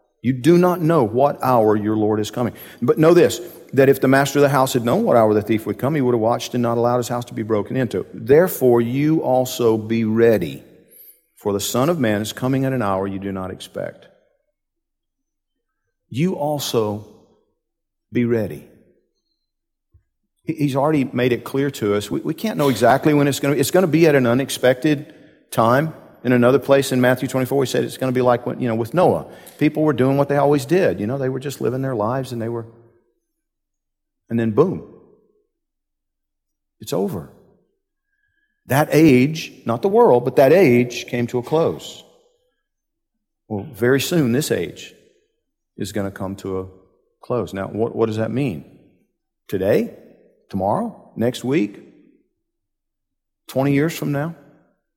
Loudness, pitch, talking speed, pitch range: -19 LUFS, 130 Hz, 180 wpm, 115-155 Hz